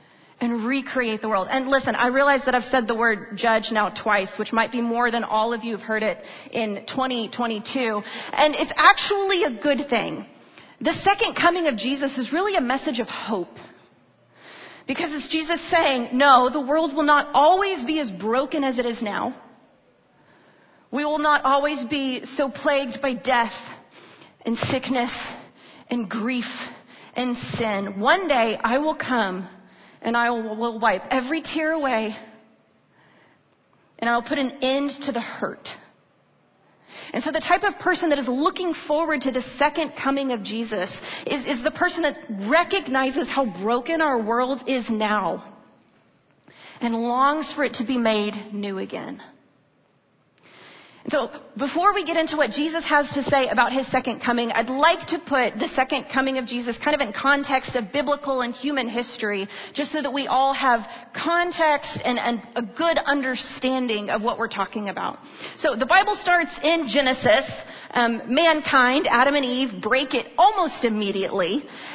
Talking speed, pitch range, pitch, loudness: 165 wpm, 235-295 Hz, 260 Hz, -22 LUFS